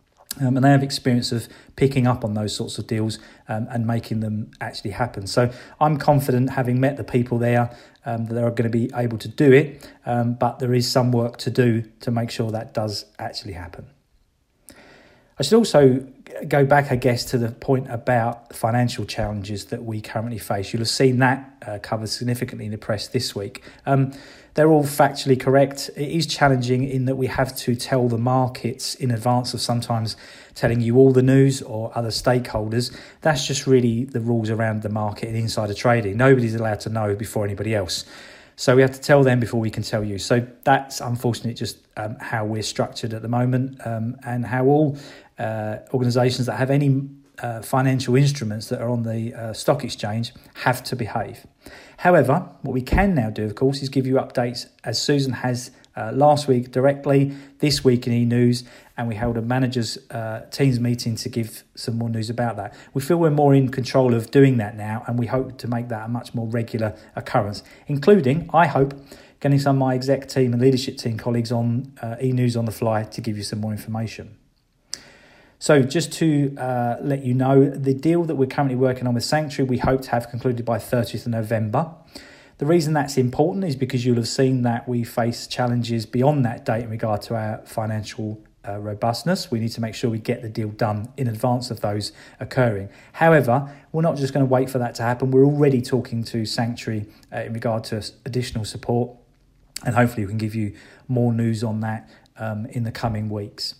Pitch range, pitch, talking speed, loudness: 115-135 Hz, 120 Hz, 205 wpm, -22 LUFS